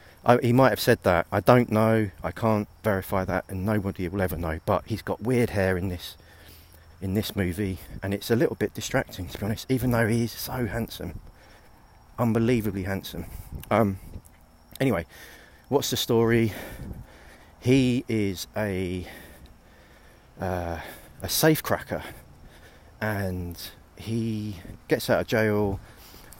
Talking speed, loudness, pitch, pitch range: 145 wpm, -26 LUFS, 100 Hz, 90-115 Hz